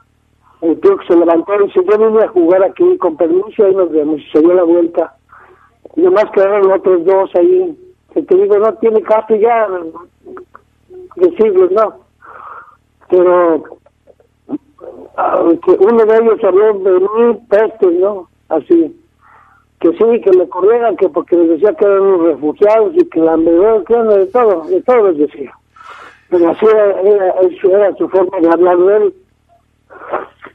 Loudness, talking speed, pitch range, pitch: -11 LUFS, 160 wpm, 180-275 Hz, 200 Hz